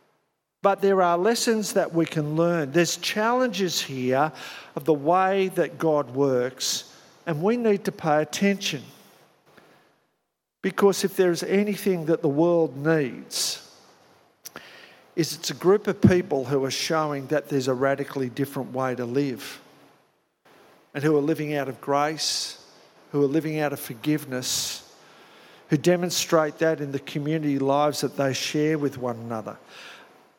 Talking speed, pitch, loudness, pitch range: 145 wpm, 155 Hz, -24 LUFS, 140-175 Hz